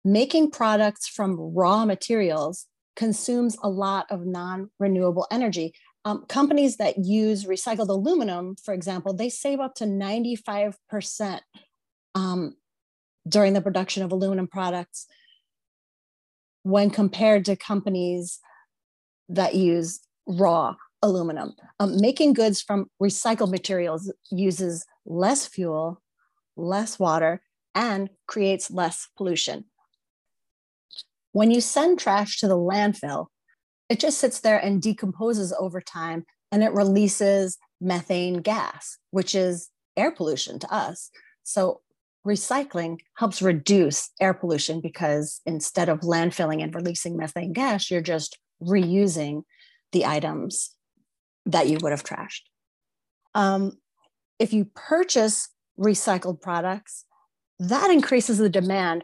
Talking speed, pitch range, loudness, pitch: 115 wpm, 180-215 Hz, -24 LUFS, 195 Hz